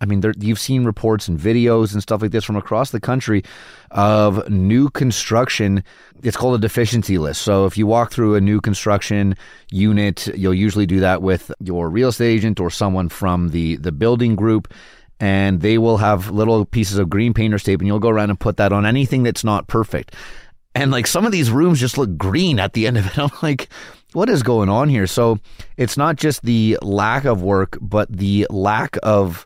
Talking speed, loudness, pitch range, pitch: 210 wpm, -17 LUFS, 100-120 Hz, 105 Hz